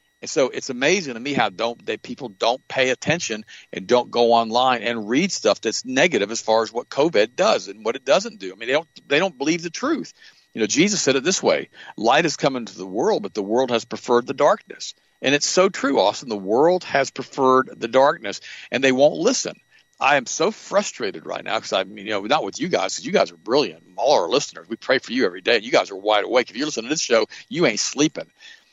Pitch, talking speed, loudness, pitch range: 130 Hz, 255 wpm, -21 LUFS, 120-155 Hz